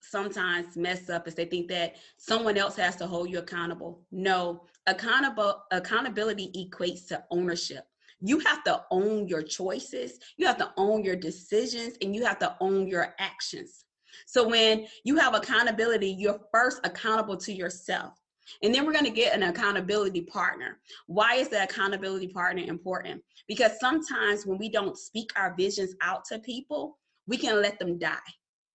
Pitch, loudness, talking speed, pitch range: 195 Hz, -28 LUFS, 165 wpm, 180-225 Hz